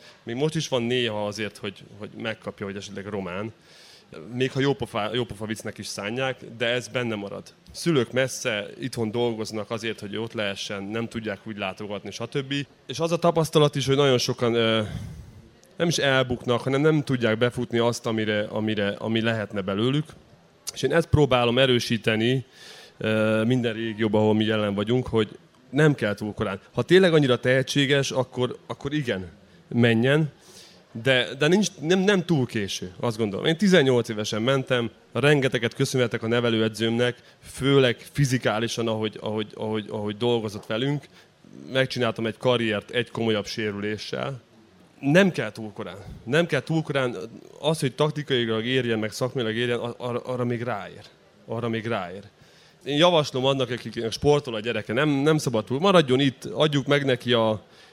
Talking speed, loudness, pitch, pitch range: 155 wpm, -24 LUFS, 120 Hz, 110-135 Hz